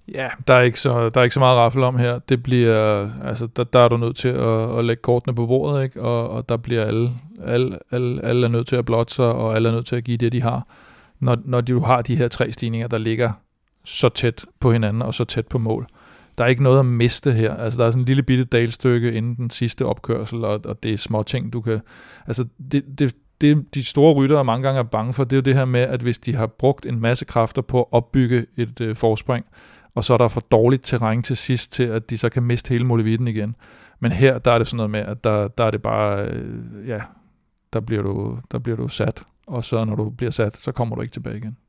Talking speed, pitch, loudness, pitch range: 260 wpm, 120 Hz, -20 LUFS, 115-125 Hz